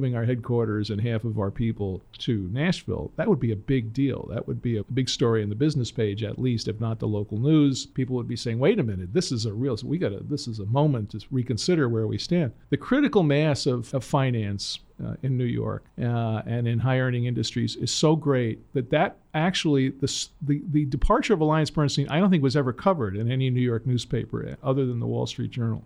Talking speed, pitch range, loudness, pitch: 230 wpm, 115-145 Hz, -25 LUFS, 125 Hz